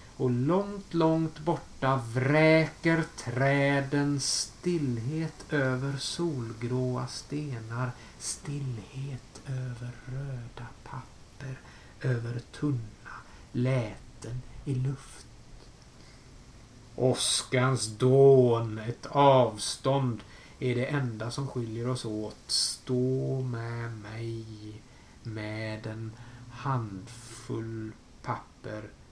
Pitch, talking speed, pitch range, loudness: 125 Hz, 75 wpm, 115-135 Hz, -29 LUFS